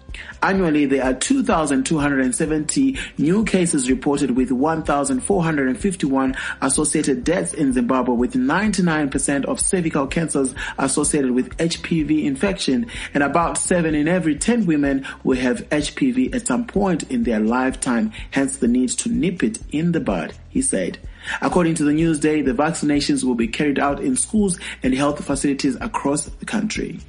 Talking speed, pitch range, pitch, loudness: 150 wpm, 140-200 Hz, 155 Hz, -20 LUFS